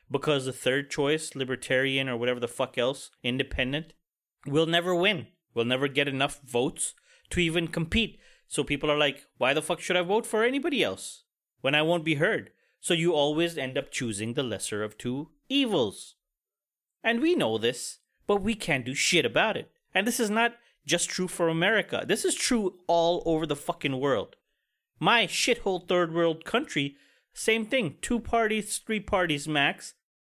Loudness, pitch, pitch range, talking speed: -27 LUFS, 160 Hz, 135-200 Hz, 180 wpm